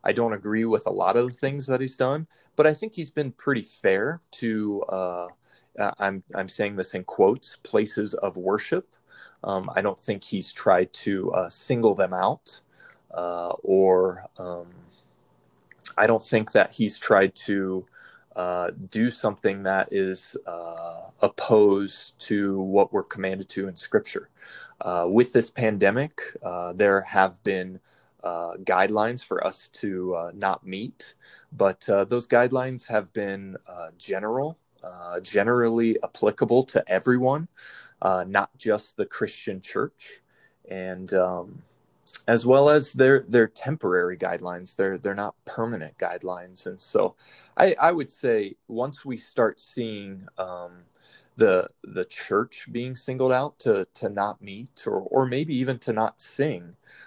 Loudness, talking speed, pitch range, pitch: -25 LUFS, 150 wpm, 95-125 Hz, 100 Hz